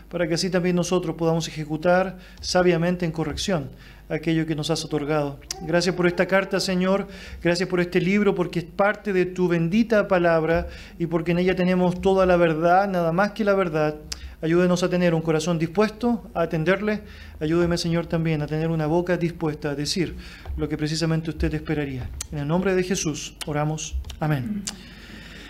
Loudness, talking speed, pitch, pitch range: -23 LUFS, 175 wpm, 175 Hz, 160-185 Hz